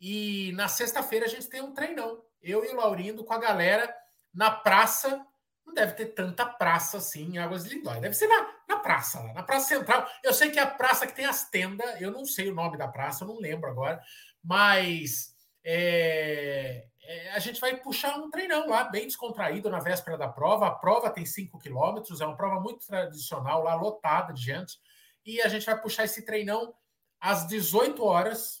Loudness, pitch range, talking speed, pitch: -28 LUFS, 170-240 Hz, 205 wpm, 215 Hz